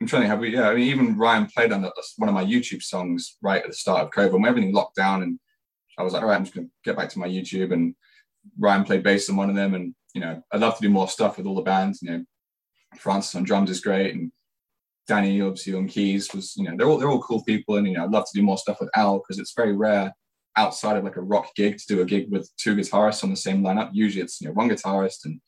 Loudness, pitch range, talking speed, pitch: -23 LUFS, 95-115 Hz, 285 wpm, 100 Hz